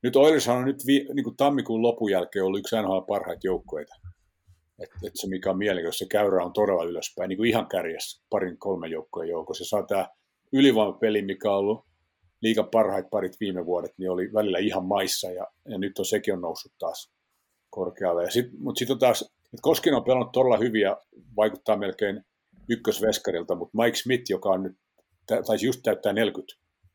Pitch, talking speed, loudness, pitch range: 105 Hz, 180 wpm, -26 LUFS, 95-125 Hz